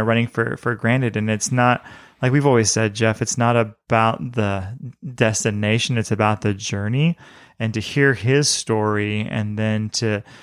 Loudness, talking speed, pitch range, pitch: -20 LUFS, 165 wpm, 110-125 Hz, 115 Hz